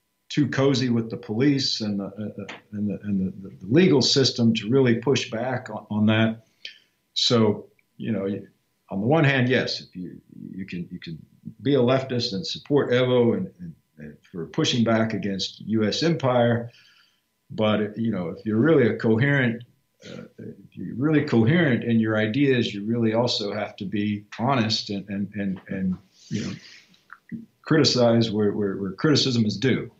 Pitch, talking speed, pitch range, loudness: 115 Hz, 175 wpm, 105-130 Hz, -23 LUFS